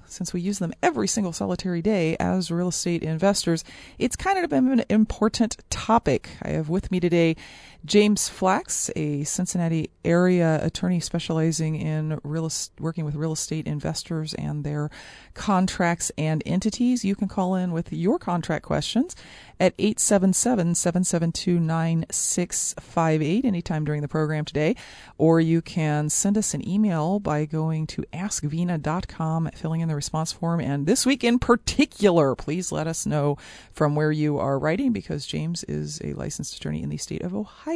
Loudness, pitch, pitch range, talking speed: -24 LUFS, 165 Hz, 155-190 Hz, 155 wpm